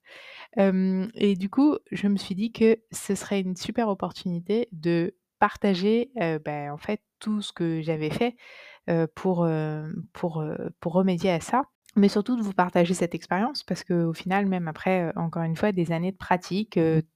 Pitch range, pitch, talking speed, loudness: 170-210 Hz, 185 Hz, 195 wpm, -26 LUFS